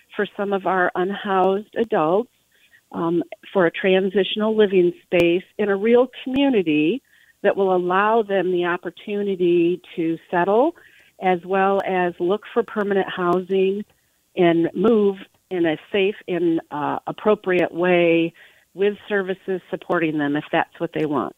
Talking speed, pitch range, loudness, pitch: 140 wpm, 175-205 Hz, -21 LUFS, 190 Hz